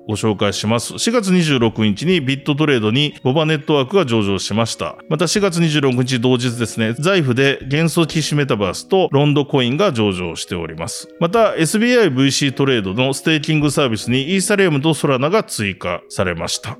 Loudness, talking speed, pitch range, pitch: -17 LUFS, 395 characters per minute, 115-160 Hz, 140 Hz